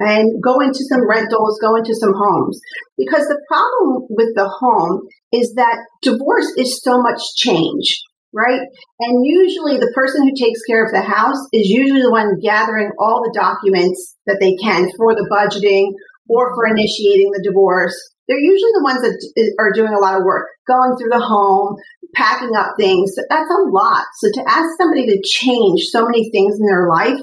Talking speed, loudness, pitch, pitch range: 190 wpm, -14 LUFS, 230 Hz, 205-270 Hz